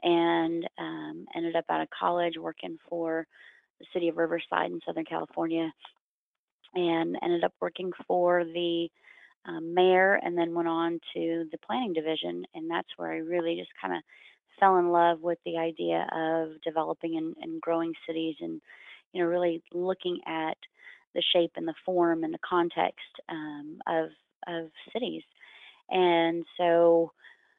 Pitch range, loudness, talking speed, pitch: 165-175 Hz, -29 LUFS, 155 wpm, 170 Hz